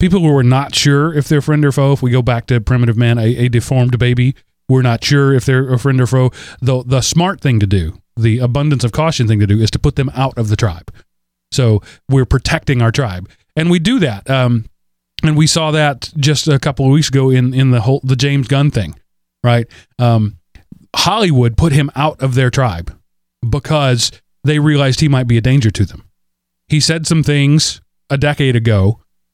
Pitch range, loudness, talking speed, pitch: 115-145 Hz, -13 LUFS, 215 wpm, 130 Hz